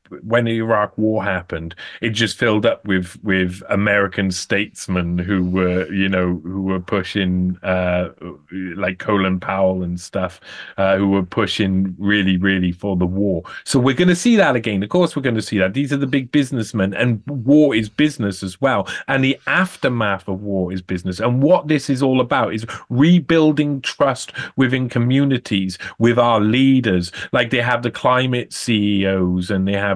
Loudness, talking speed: -18 LUFS, 180 wpm